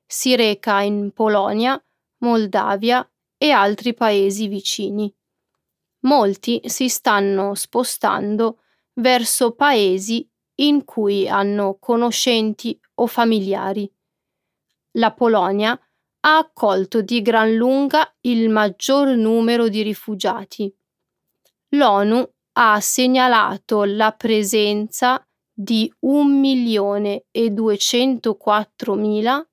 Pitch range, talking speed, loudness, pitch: 205-245 Hz, 80 wpm, -18 LUFS, 225 Hz